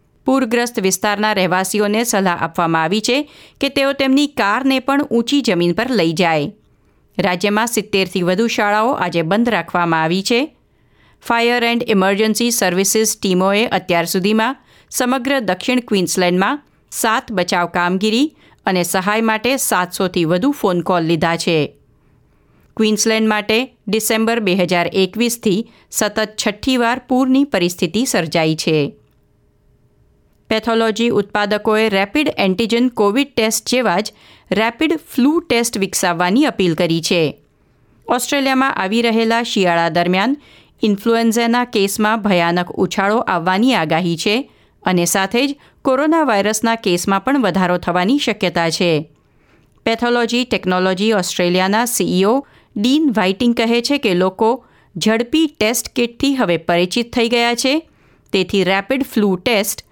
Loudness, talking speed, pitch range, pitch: -16 LUFS, 120 wpm, 185-240 Hz, 215 Hz